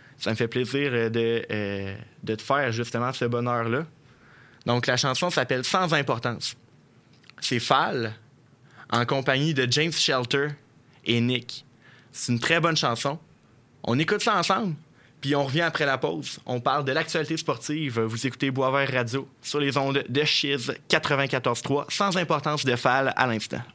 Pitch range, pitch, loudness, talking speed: 120-150 Hz, 135 Hz, -25 LUFS, 155 wpm